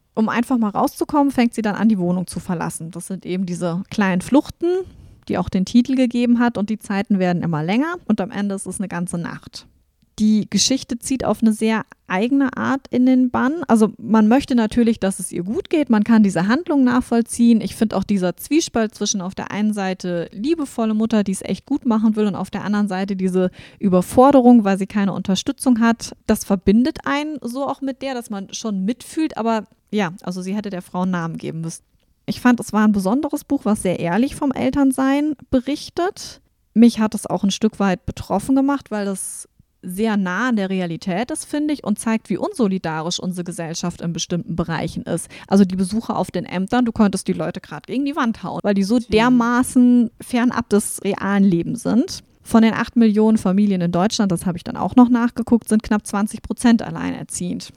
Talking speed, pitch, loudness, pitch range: 210 wpm, 215 Hz, -19 LUFS, 190-245 Hz